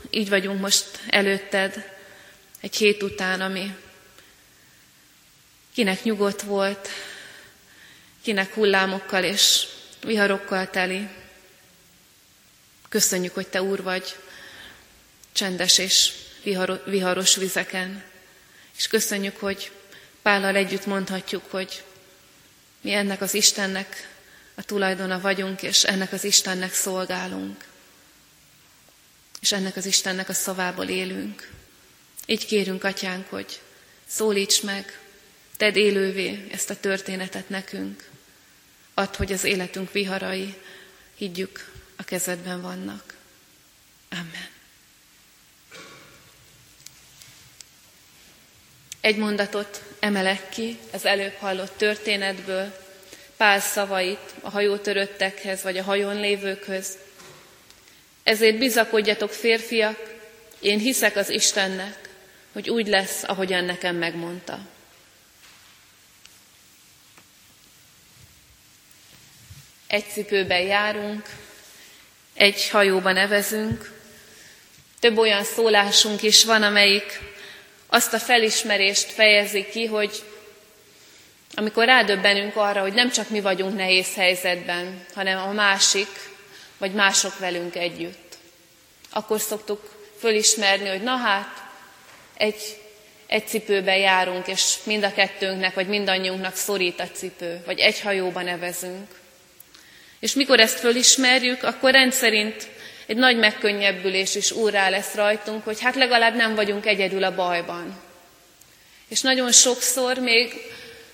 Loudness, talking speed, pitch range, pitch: -21 LUFS, 100 wpm, 185-210 Hz, 195 Hz